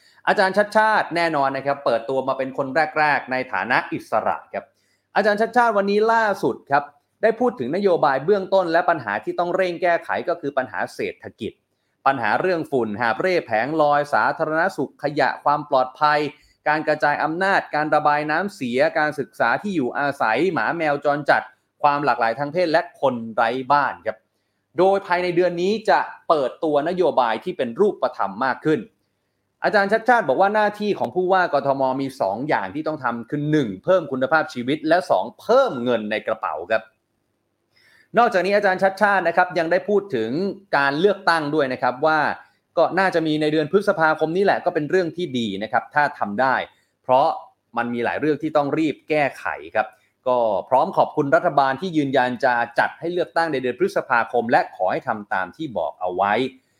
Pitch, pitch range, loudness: 155 Hz, 135-185 Hz, -21 LUFS